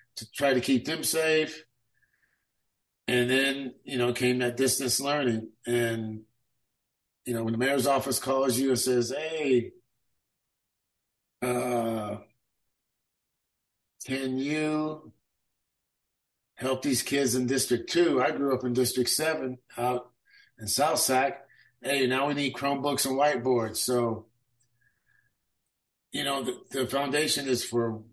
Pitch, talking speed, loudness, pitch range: 125 Hz, 130 wpm, -27 LUFS, 120-140 Hz